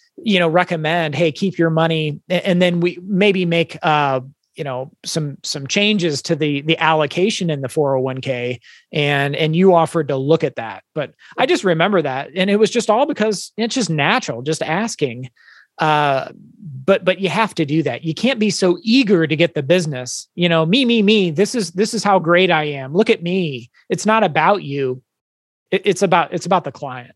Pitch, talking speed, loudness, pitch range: 170 Hz, 205 wpm, -17 LUFS, 150-195 Hz